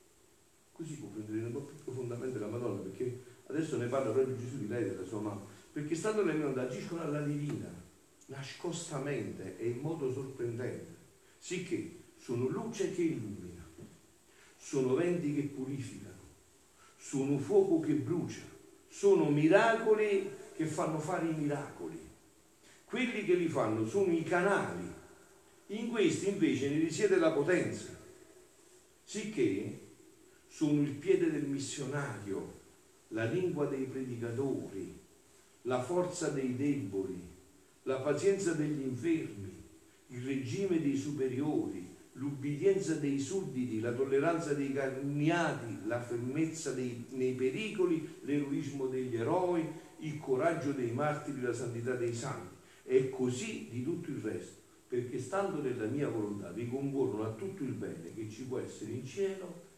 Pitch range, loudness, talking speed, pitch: 125-175 Hz, -35 LUFS, 135 wpm, 140 Hz